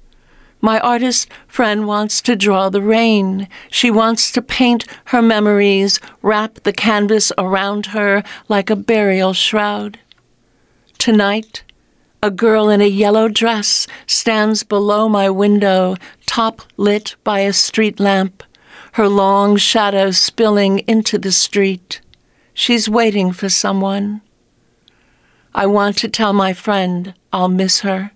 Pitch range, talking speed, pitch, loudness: 195-220 Hz, 130 wpm, 205 Hz, -14 LUFS